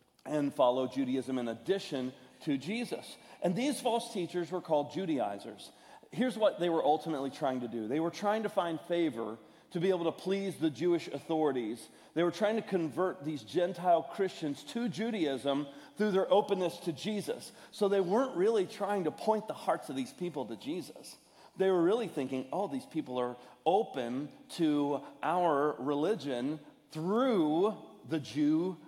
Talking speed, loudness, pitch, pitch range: 165 wpm, -33 LUFS, 170 Hz, 145-200 Hz